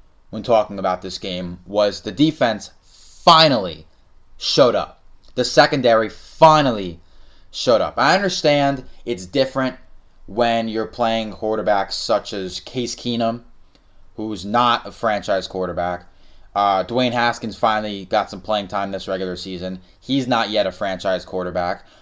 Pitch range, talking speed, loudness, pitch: 90-120 Hz, 135 wpm, -19 LUFS, 100 Hz